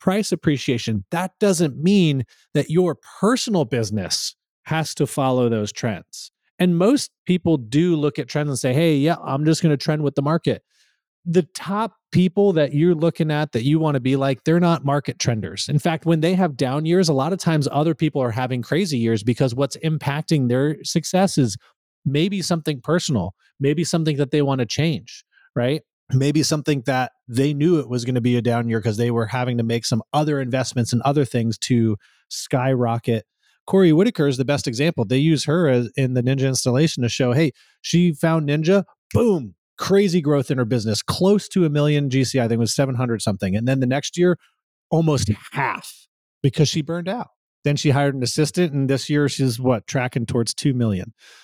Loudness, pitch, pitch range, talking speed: -20 LUFS, 145 Hz, 125-165 Hz, 205 wpm